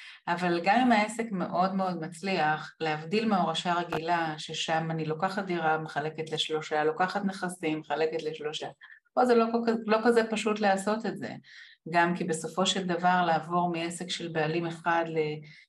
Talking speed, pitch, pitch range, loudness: 155 wpm, 175 Hz, 160-195 Hz, -29 LUFS